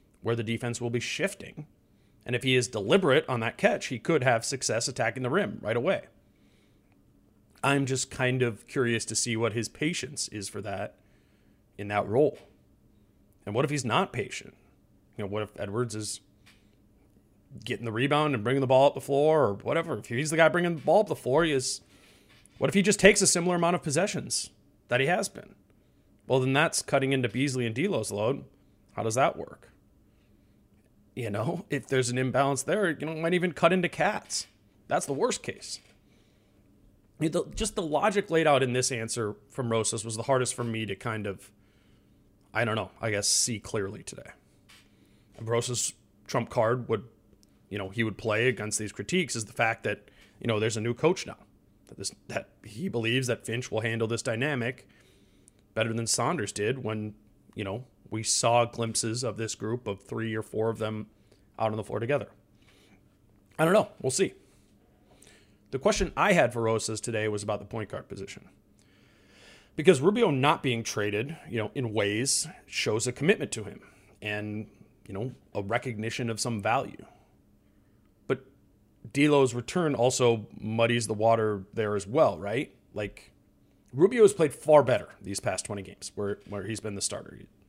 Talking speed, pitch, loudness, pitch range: 185 wpm, 115 Hz, -28 LUFS, 105-130 Hz